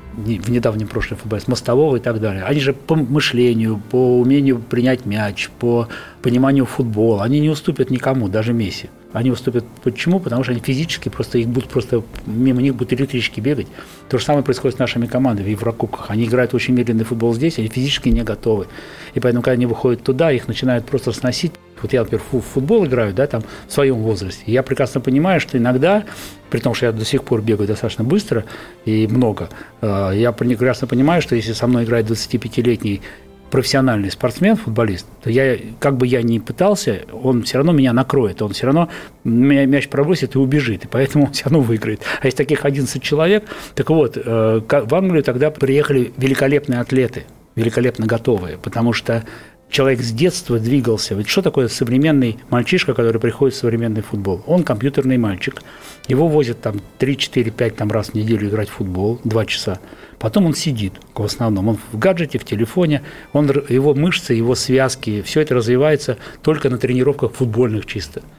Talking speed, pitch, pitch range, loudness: 180 wpm, 125 Hz, 115-135 Hz, -17 LUFS